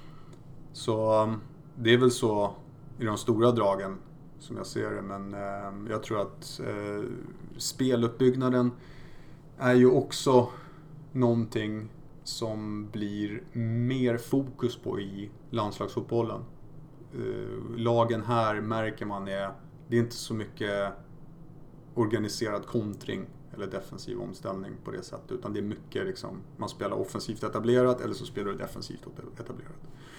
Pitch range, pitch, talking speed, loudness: 110-140 Hz, 120 Hz, 125 wpm, -30 LUFS